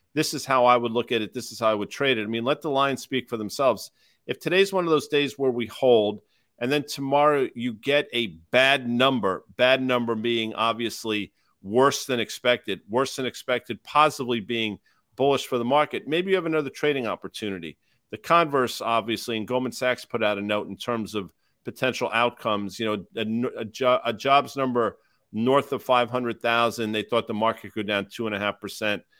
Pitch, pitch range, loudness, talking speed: 120 Hz, 110-135 Hz, -24 LUFS, 195 wpm